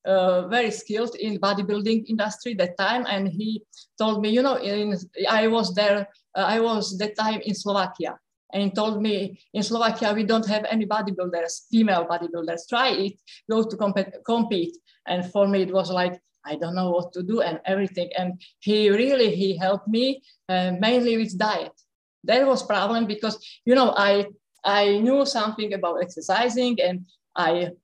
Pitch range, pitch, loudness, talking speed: 185-220 Hz, 205 Hz, -24 LUFS, 175 wpm